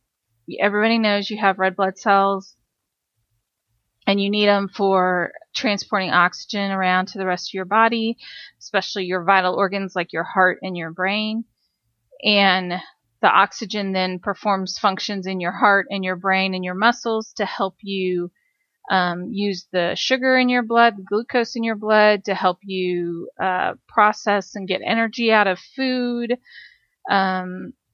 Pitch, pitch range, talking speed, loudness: 195 Hz, 185-210 Hz, 155 wpm, -20 LUFS